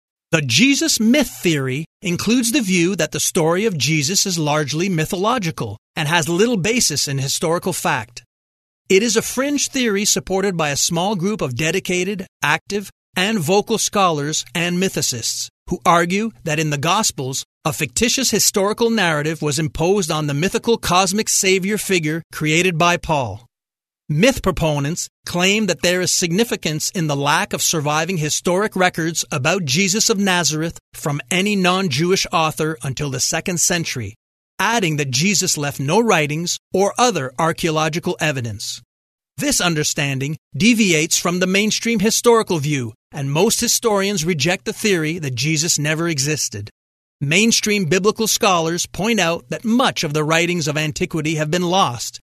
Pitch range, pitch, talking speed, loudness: 155-200 Hz, 175 Hz, 150 wpm, -18 LUFS